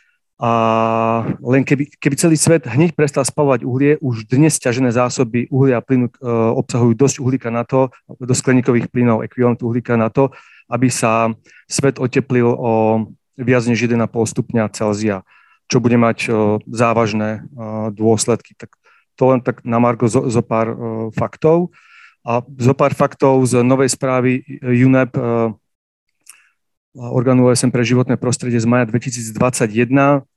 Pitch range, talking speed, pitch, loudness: 115-135 Hz, 145 wpm, 125 Hz, -16 LUFS